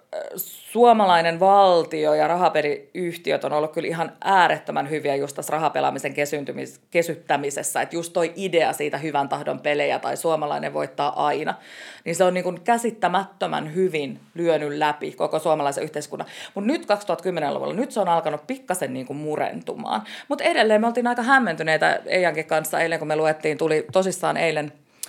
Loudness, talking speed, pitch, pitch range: -22 LUFS, 155 wpm, 165 Hz, 150-190 Hz